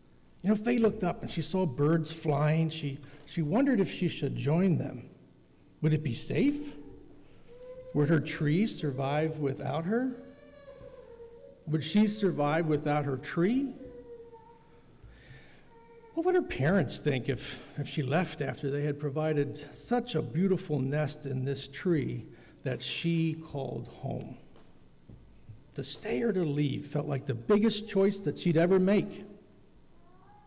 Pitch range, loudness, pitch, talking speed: 145-215 Hz, -30 LUFS, 160 Hz, 145 wpm